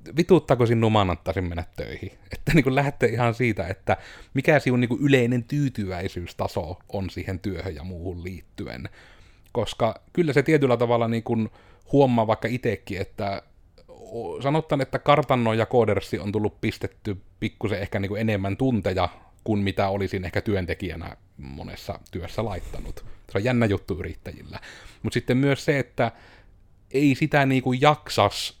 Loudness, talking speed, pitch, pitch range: -24 LUFS, 145 wpm, 110 Hz, 95-130 Hz